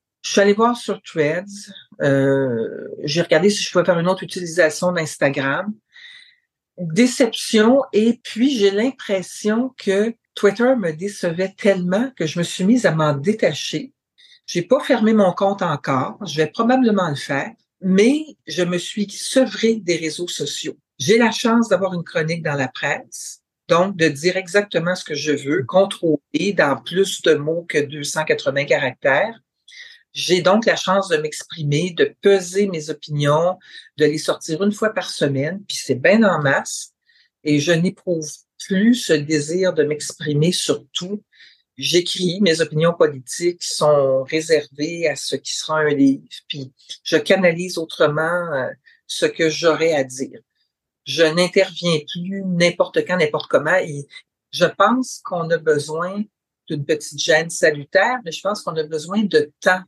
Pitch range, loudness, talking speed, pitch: 155-205 Hz, -19 LUFS, 155 wpm, 180 Hz